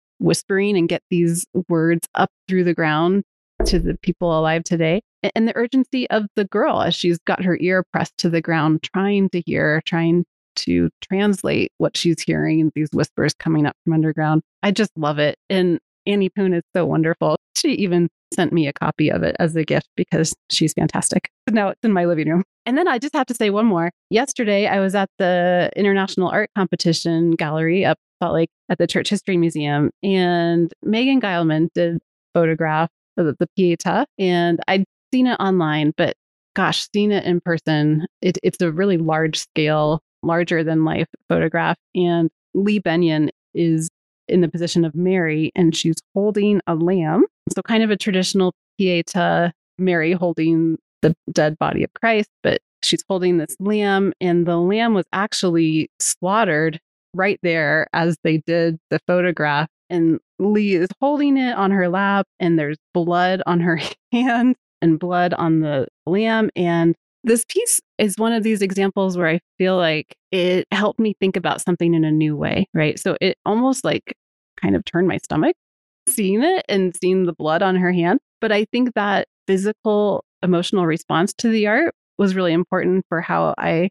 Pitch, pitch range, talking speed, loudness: 180 Hz, 165-200 Hz, 180 wpm, -19 LUFS